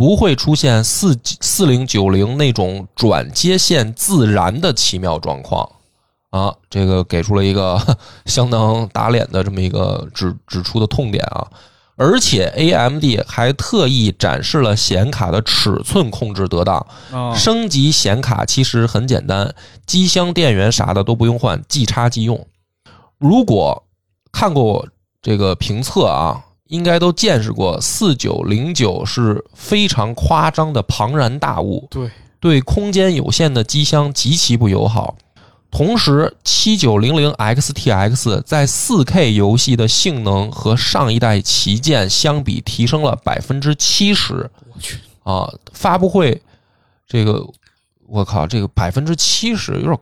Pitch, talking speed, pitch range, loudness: 120 Hz, 220 characters per minute, 105-145 Hz, -15 LUFS